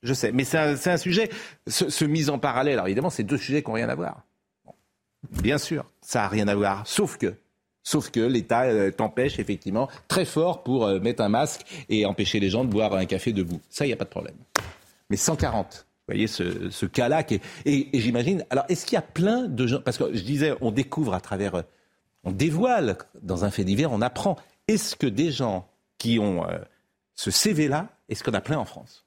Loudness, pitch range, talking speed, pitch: -25 LUFS, 105-155 Hz, 220 wpm, 130 Hz